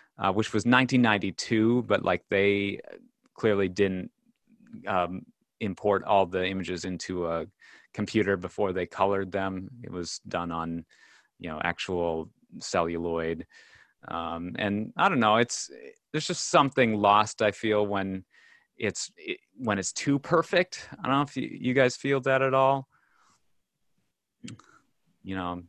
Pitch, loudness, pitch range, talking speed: 100 Hz, -27 LUFS, 95-130 Hz, 145 wpm